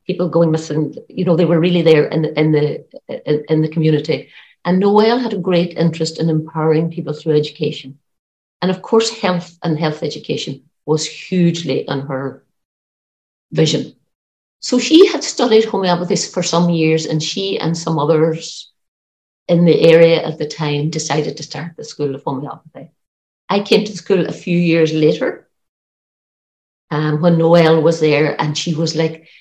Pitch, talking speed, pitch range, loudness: 160 Hz, 165 wpm, 150-175 Hz, -16 LUFS